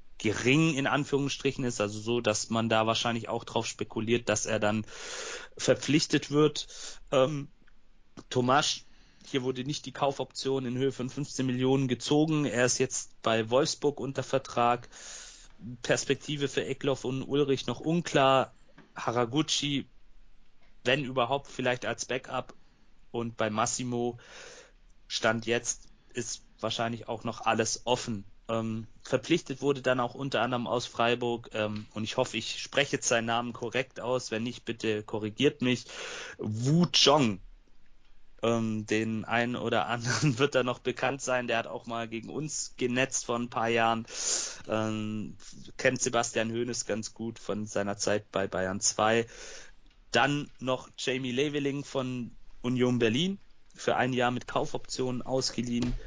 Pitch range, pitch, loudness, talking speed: 115-135 Hz, 120 Hz, -30 LUFS, 145 wpm